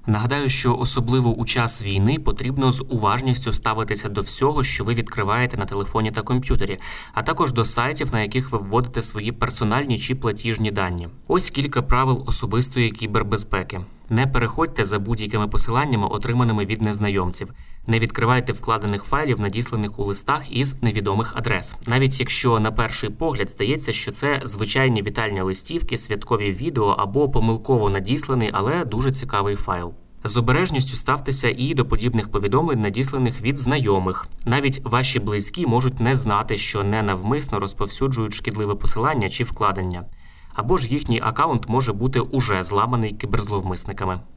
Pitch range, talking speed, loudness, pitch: 105-130 Hz, 145 wpm, -21 LUFS, 115 Hz